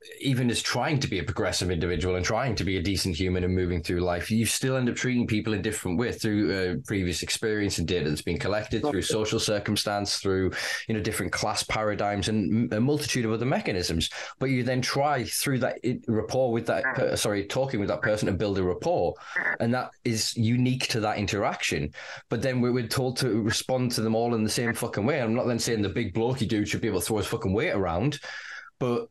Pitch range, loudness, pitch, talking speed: 100-120 Hz, -27 LUFS, 110 Hz, 225 wpm